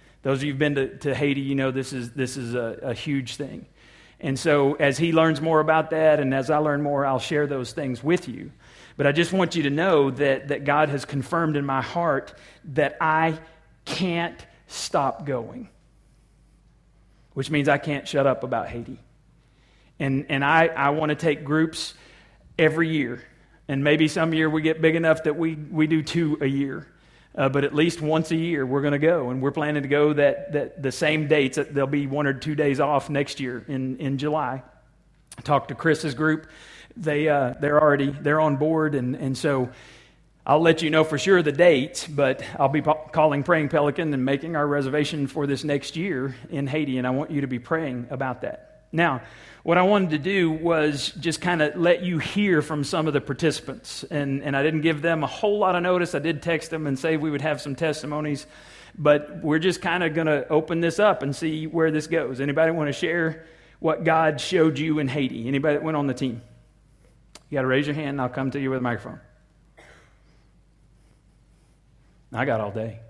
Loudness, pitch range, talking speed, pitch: -23 LUFS, 140-160 Hz, 215 wpm, 150 Hz